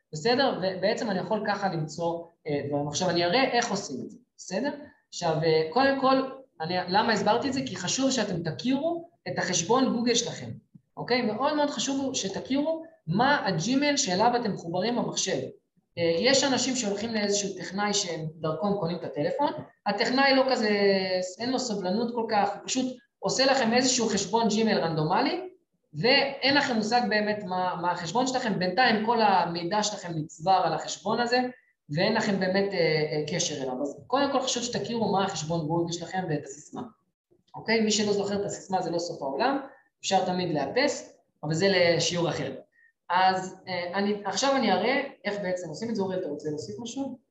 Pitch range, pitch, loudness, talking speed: 180-250 Hz, 205 Hz, -27 LUFS, 170 wpm